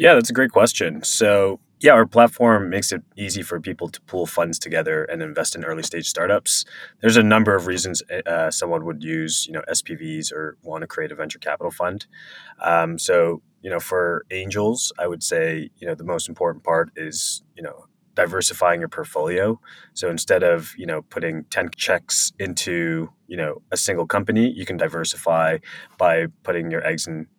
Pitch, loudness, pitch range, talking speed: 95 Hz, -21 LUFS, 80-115 Hz, 190 wpm